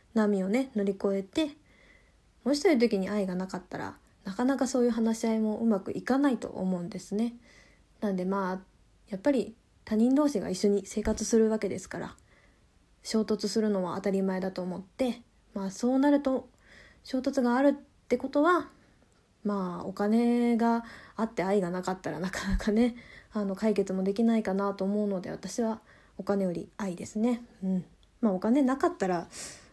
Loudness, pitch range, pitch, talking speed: -29 LUFS, 195-240 Hz, 215 Hz, 335 characters per minute